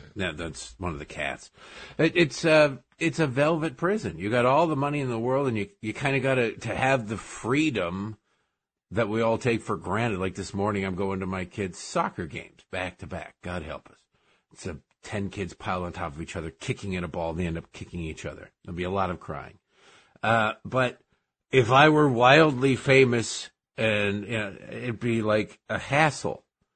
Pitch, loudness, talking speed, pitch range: 110 Hz, -26 LUFS, 215 wpm, 95-135 Hz